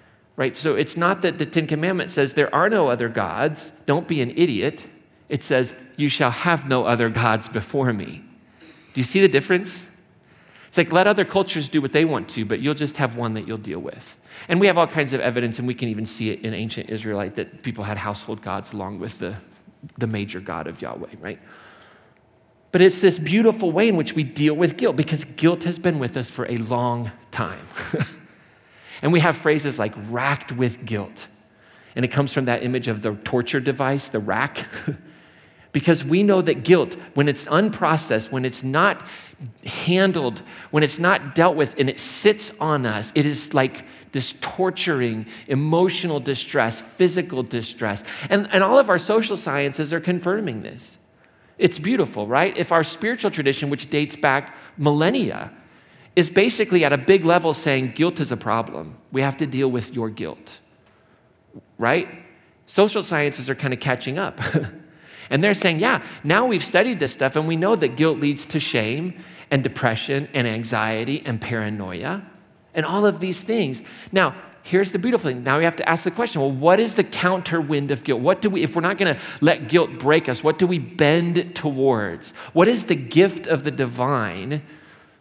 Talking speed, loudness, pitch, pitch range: 190 wpm, -21 LUFS, 145 Hz, 120-175 Hz